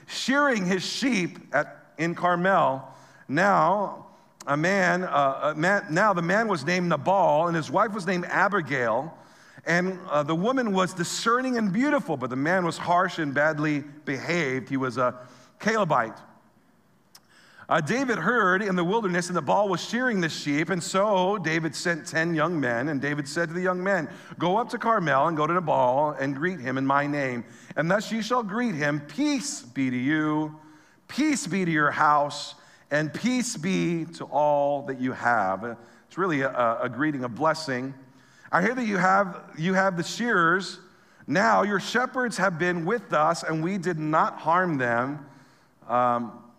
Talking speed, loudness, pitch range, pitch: 180 wpm, -25 LUFS, 145-195 Hz, 170 Hz